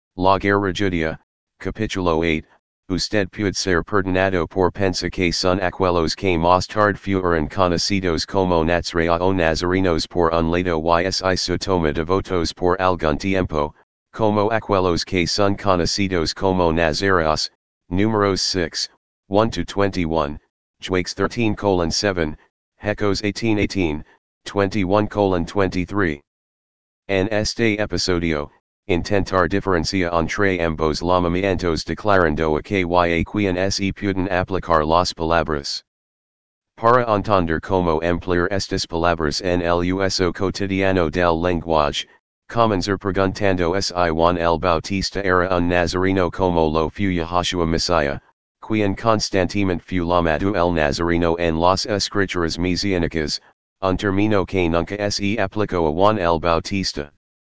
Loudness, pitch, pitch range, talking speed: -20 LUFS, 90 Hz, 85-100 Hz, 115 wpm